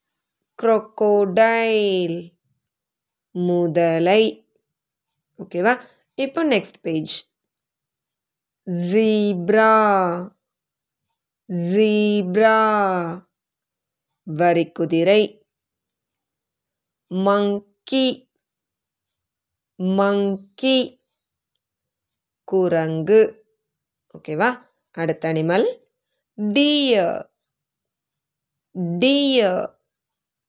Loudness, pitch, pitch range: -19 LUFS, 200 Hz, 170-225 Hz